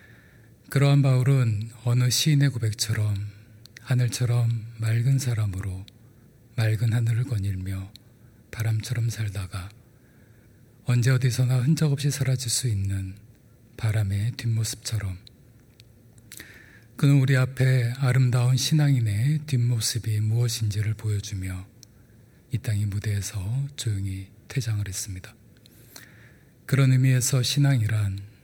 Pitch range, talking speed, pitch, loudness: 110-125 Hz, 250 characters per minute, 115 Hz, -25 LUFS